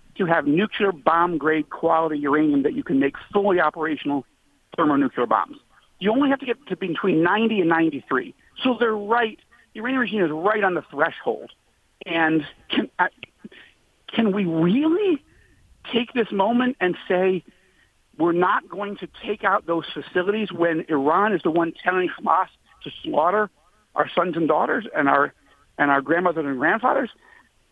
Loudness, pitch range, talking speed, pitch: -22 LUFS, 160-210 Hz, 160 wpm, 180 Hz